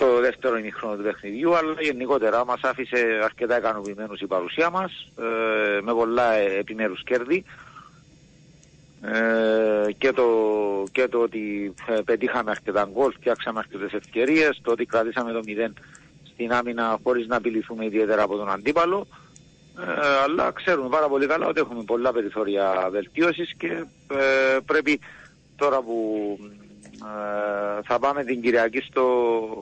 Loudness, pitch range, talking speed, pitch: -24 LUFS, 105-130 Hz, 125 wpm, 115 Hz